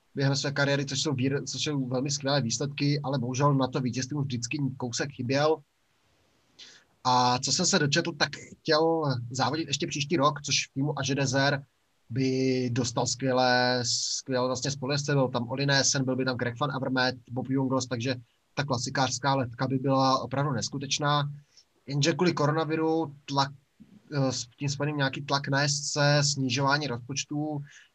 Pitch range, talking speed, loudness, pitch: 130-145 Hz, 155 wpm, -27 LUFS, 140 Hz